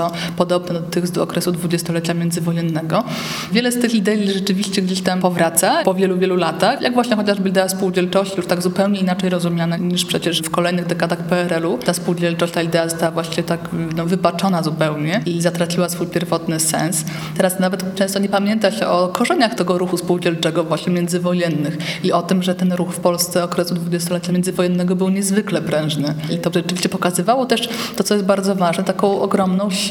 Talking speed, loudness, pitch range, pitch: 180 wpm, -18 LUFS, 170-190 Hz, 180 Hz